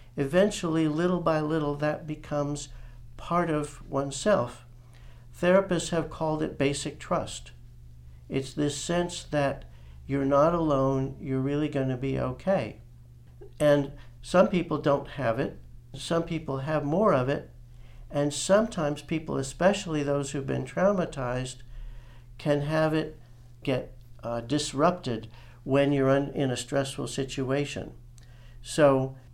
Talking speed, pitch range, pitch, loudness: 125 wpm, 120-155 Hz, 140 Hz, -28 LUFS